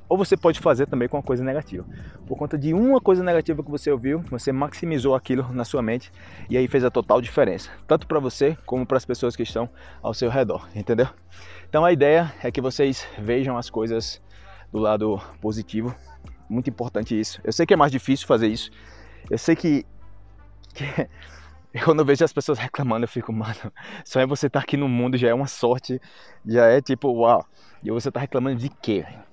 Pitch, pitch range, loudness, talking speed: 125 Hz, 110-145 Hz, -23 LUFS, 205 wpm